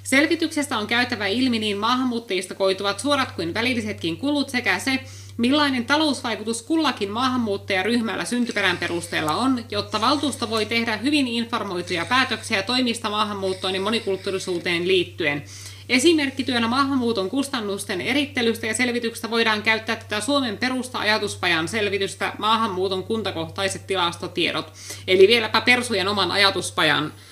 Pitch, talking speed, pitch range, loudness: 225 Hz, 115 wpm, 195-250 Hz, -22 LUFS